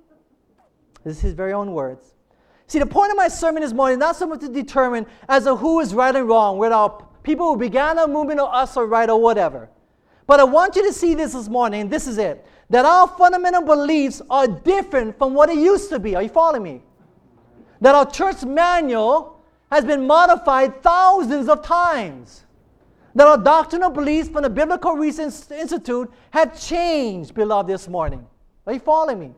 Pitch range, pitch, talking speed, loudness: 235-320 Hz, 290 Hz, 195 wpm, -17 LUFS